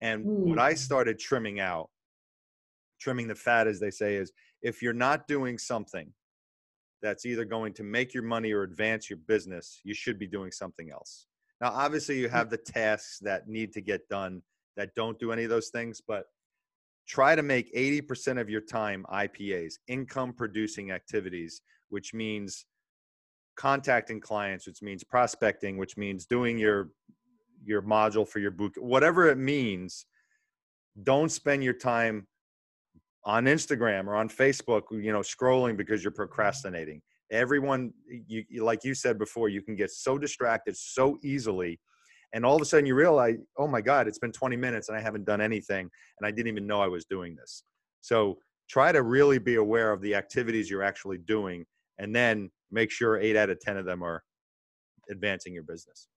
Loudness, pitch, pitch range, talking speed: -29 LUFS, 110 Hz, 100-120 Hz, 175 wpm